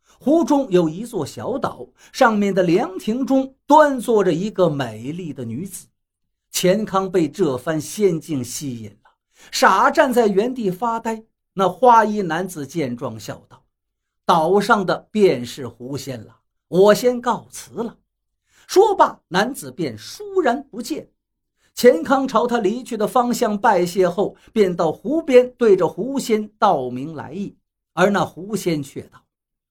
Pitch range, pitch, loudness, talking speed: 155-240 Hz, 195 Hz, -19 LUFS, 205 characters per minute